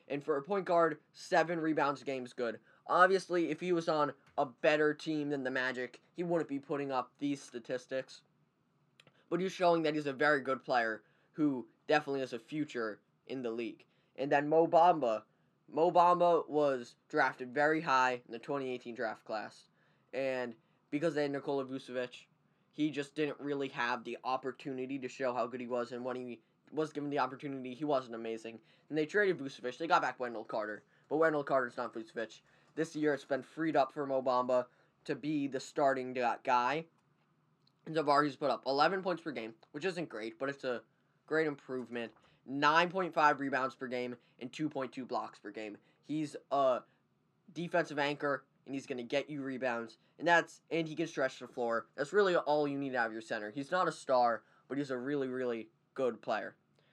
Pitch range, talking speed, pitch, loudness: 125-155 Hz, 190 wpm, 140 Hz, -34 LUFS